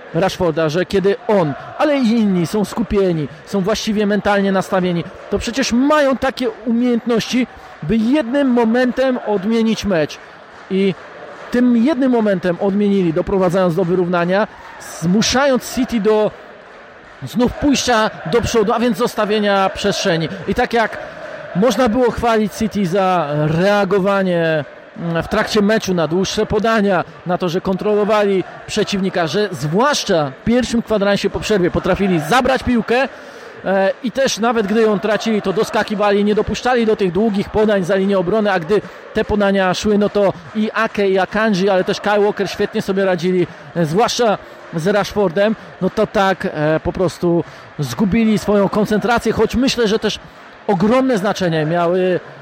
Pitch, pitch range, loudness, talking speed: 205 Hz, 185-230 Hz, -16 LUFS, 145 wpm